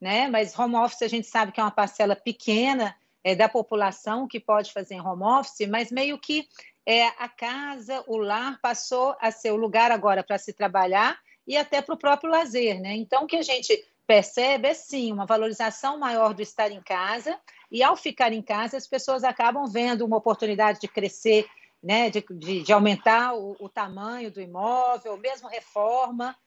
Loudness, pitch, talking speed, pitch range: -24 LUFS, 225 Hz, 195 wpm, 210-255 Hz